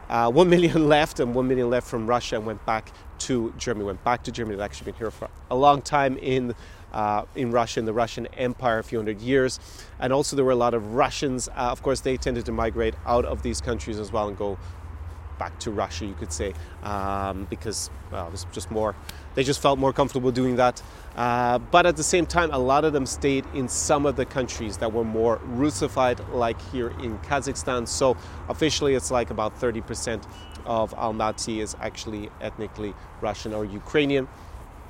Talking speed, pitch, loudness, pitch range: 205 wpm, 115 Hz, -25 LUFS, 100-130 Hz